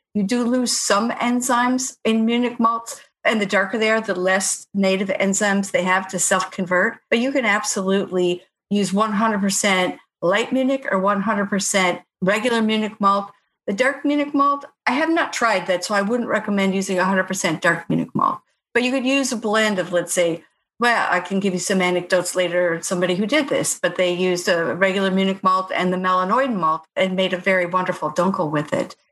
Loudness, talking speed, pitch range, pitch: -20 LUFS, 190 wpm, 185-230 Hz, 195 Hz